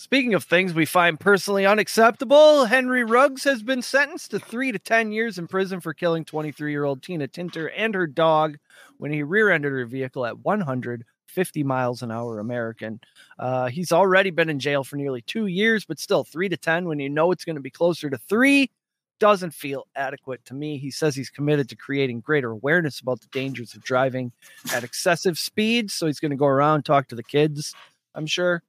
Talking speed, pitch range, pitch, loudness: 200 wpm, 135-195 Hz, 155 Hz, -22 LUFS